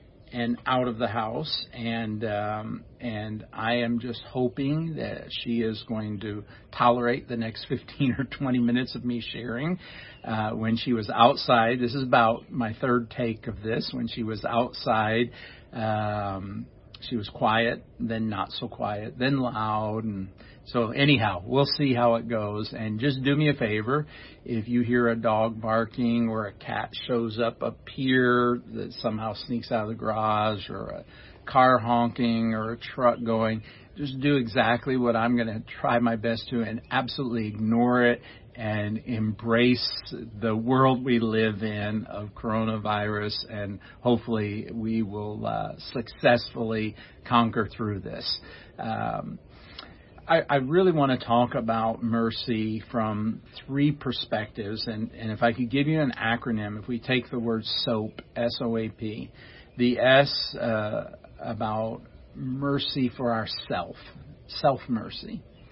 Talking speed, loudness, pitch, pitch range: 155 wpm, -27 LUFS, 115 Hz, 110-125 Hz